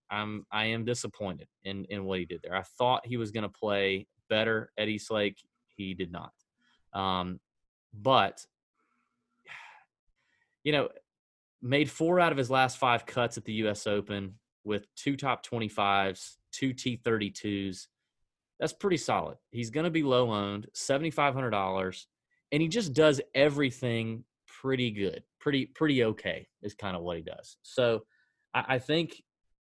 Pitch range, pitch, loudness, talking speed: 100-130 Hz, 115 Hz, -30 LUFS, 155 wpm